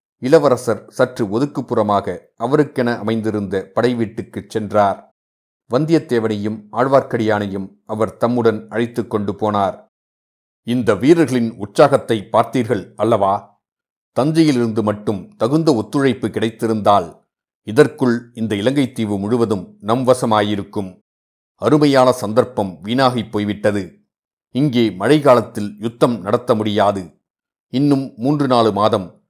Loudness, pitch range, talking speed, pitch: -17 LUFS, 105-125 Hz, 90 wpm, 115 Hz